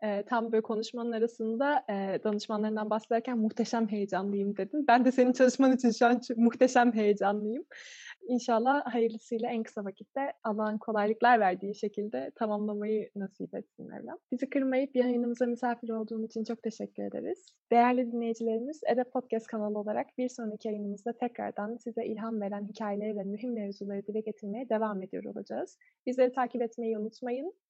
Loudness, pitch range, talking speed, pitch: -31 LUFS, 215-245 Hz, 145 wpm, 230 Hz